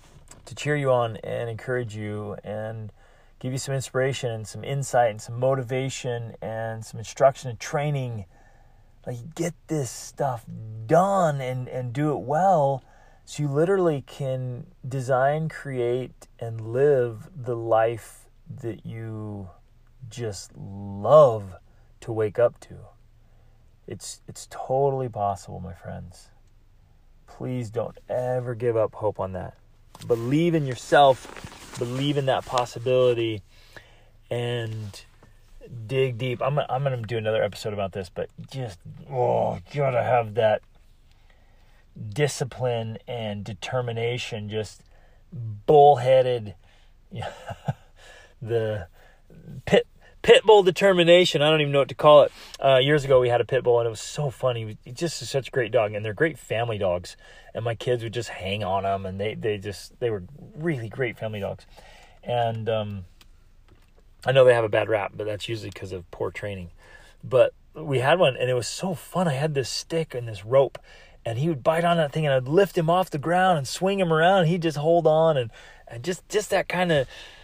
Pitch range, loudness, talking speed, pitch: 110-140 Hz, -24 LUFS, 160 wpm, 120 Hz